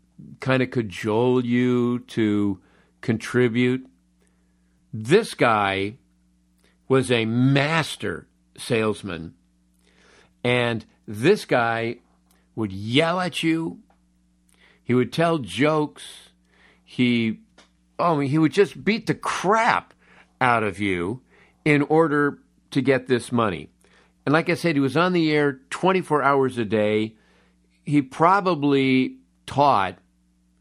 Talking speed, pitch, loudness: 115 wpm, 120 Hz, -22 LUFS